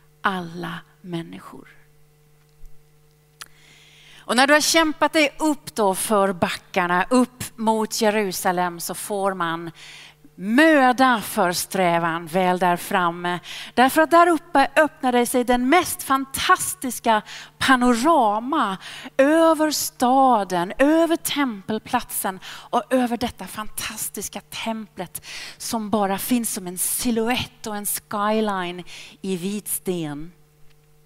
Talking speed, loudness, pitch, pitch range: 105 wpm, -21 LUFS, 210 Hz, 175-255 Hz